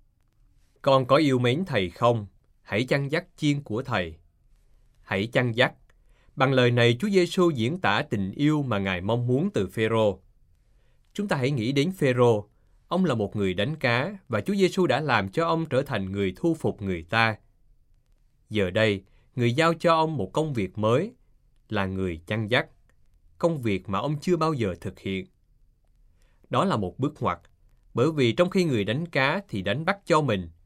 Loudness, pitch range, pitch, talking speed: -25 LUFS, 100-150 Hz, 120 Hz, 190 wpm